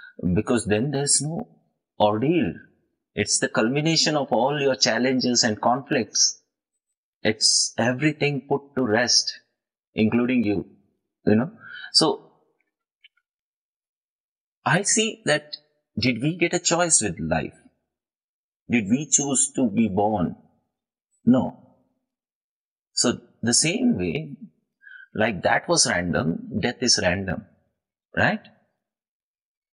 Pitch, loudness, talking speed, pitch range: 135 Hz, -22 LUFS, 105 wpm, 110-170 Hz